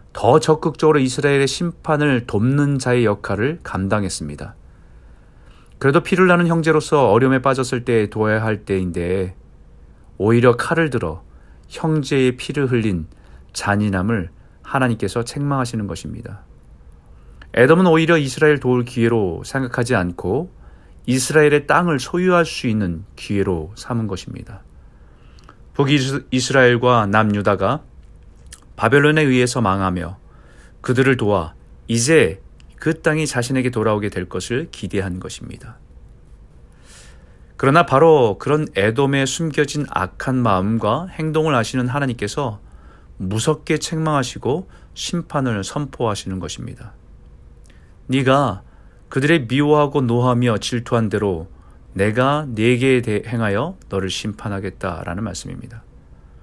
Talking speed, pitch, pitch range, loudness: 280 characters per minute, 120 Hz, 95-140 Hz, -18 LUFS